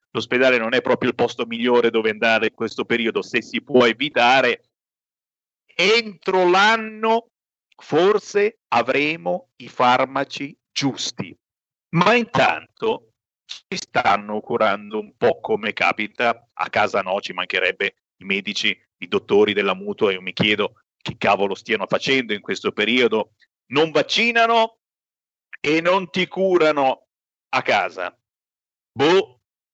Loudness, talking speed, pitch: -20 LUFS, 125 wpm, 150 Hz